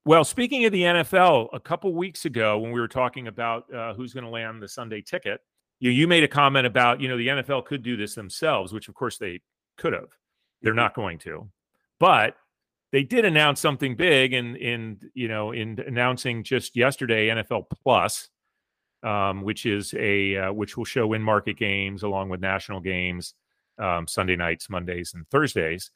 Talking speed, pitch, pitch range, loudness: 190 wpm, 115 Hz, 100-130 Hz, -24 LUFS